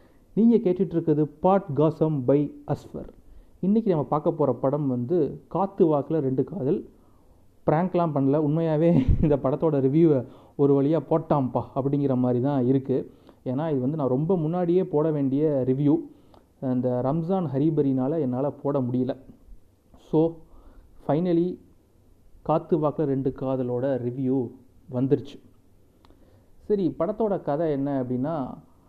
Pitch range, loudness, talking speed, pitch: 130-160 Hz, -24 LUFS, 120 wpm, 140 Hz